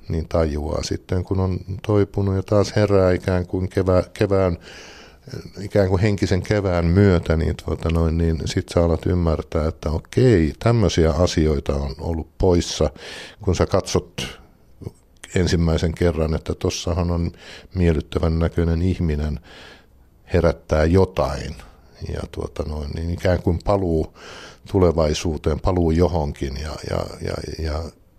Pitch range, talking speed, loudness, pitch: 80-95 Hz, 125 wpm, -21 LUFS, 85 Hz